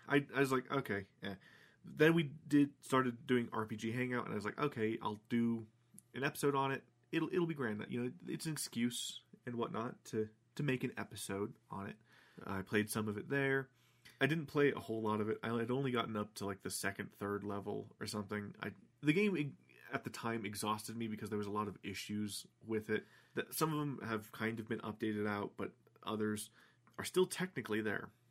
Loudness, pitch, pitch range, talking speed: -39 LUFS, 115 Hz, 105-135 Hz, 220 wpm